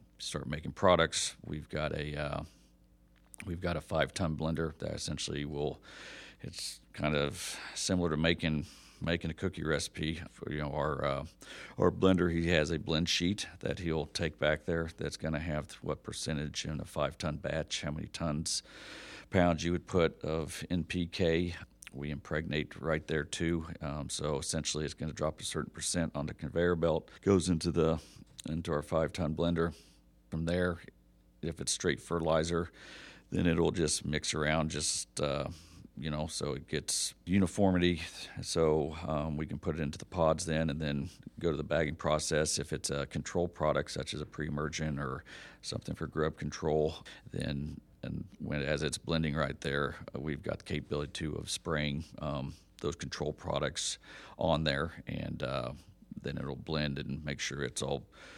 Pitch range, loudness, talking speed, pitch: 75-85 Hz, -34 LUFS, 175 wpm, 80 Hz